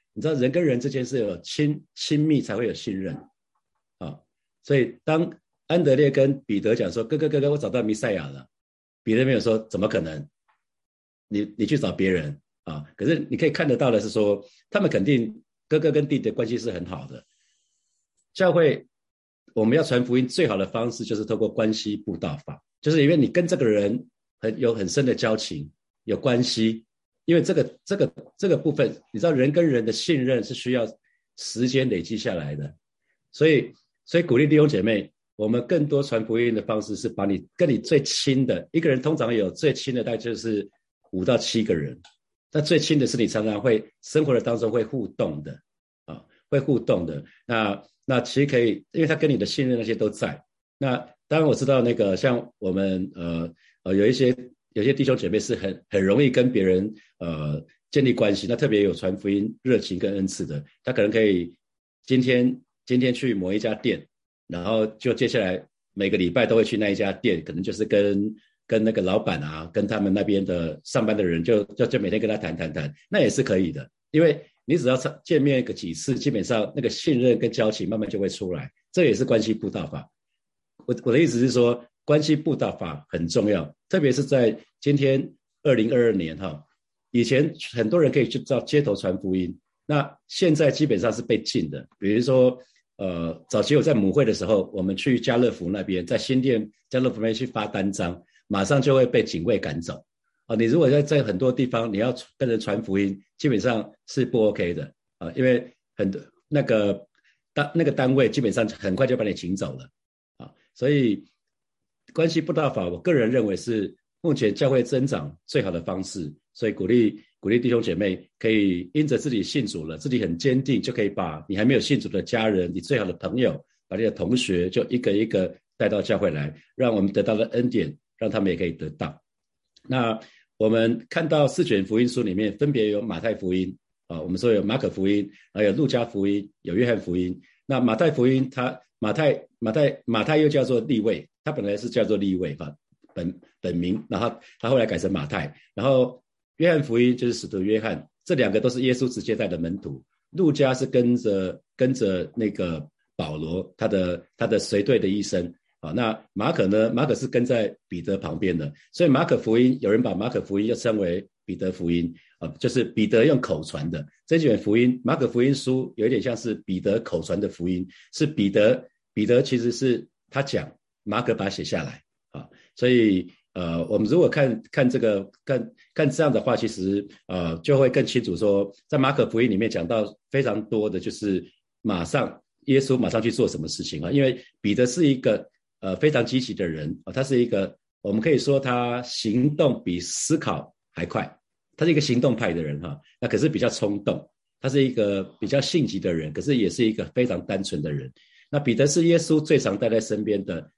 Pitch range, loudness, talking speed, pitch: 95-130 Hz, -24 LUFS, 295 characters per minute, 115 Hz